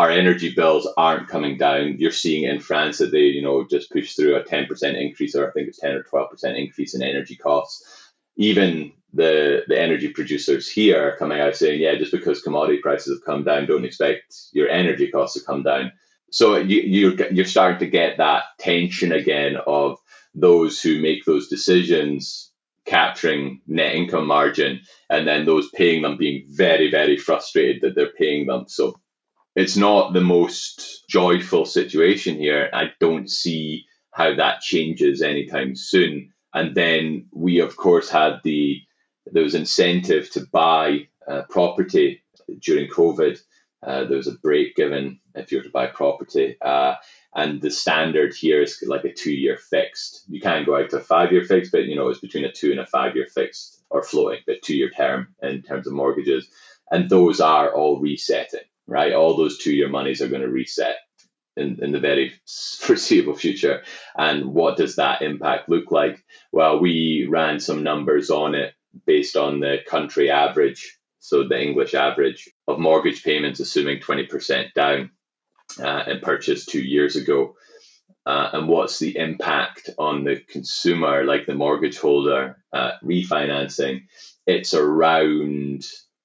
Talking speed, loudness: 170 wpm, -20 LUFS